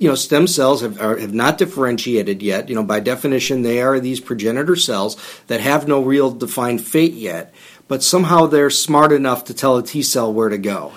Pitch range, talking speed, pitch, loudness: 115-145 Hz, 215 wpm, 130 Hz, -16 LUFS